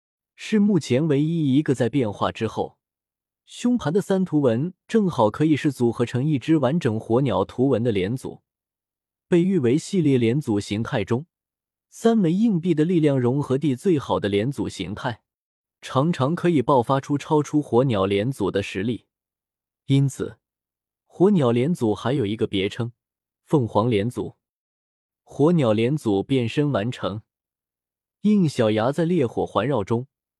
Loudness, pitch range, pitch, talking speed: -22 LUFS, 110-155 Hz, 130 Hz, 225 characters per minute